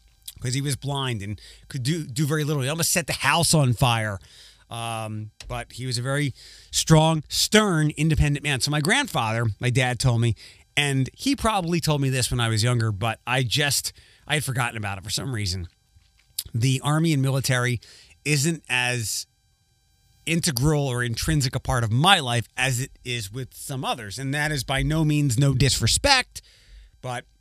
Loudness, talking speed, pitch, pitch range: -23 LUFS, 185 wpm, 130 Hz, 115-150 Hz